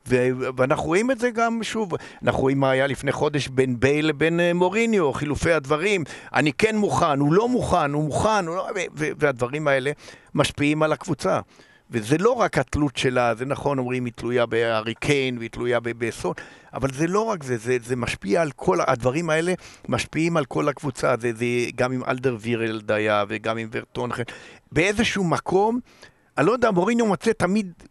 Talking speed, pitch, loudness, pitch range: 170 wpm, 140 Hz, -23 LUFS, 125-175 Hz